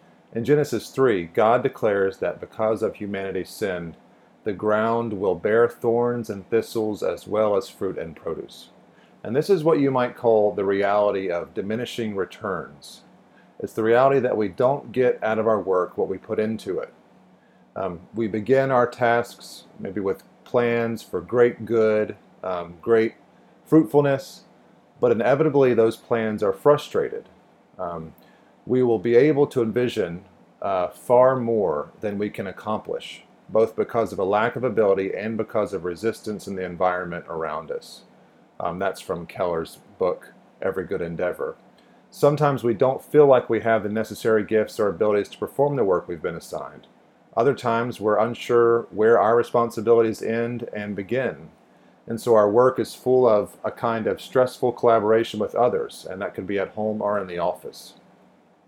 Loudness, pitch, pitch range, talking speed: -23 LUFS, 115 Hz, 105-125 Hz, 165 wpm